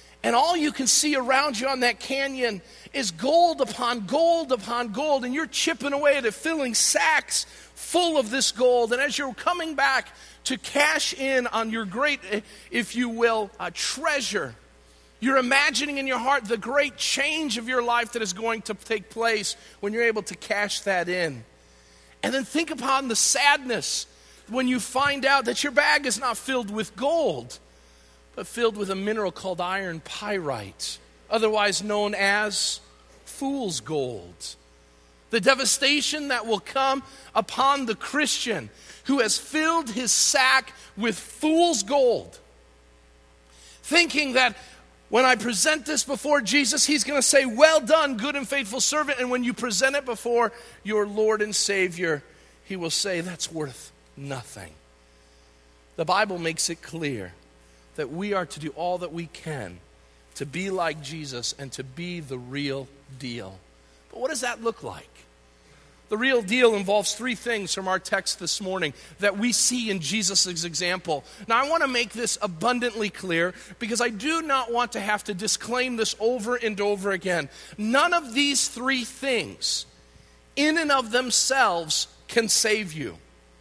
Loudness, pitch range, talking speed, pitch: -24 LUFS, 170-265 Hz, 165 wpm, 225 Hz